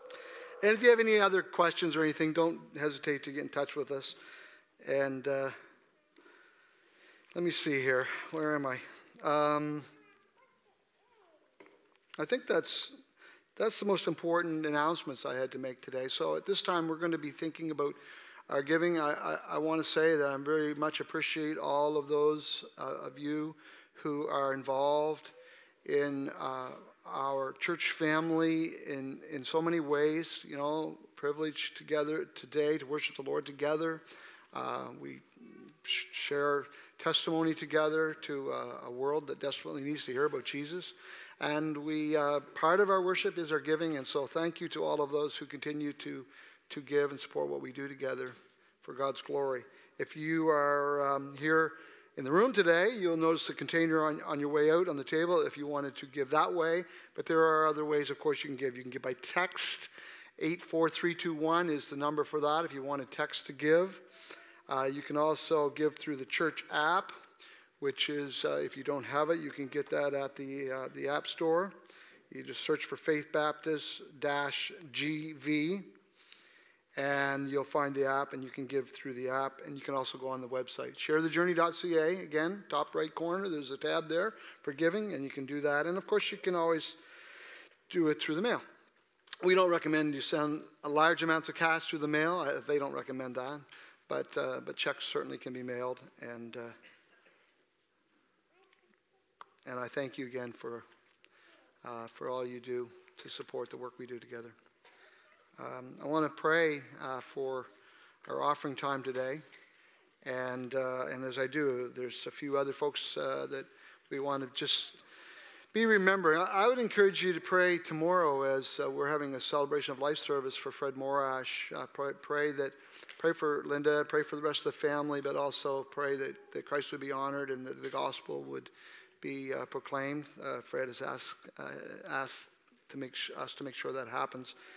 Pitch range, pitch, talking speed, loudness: 140-165 Hz, 150 Hz, 185 wpm, -33 LUFS